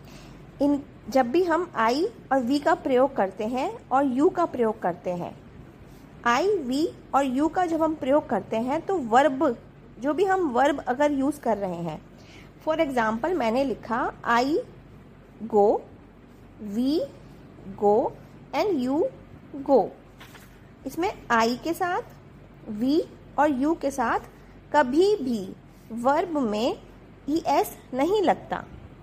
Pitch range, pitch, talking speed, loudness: 235-325 Hz, 275 Hz, 135 wpm, -25 LUFS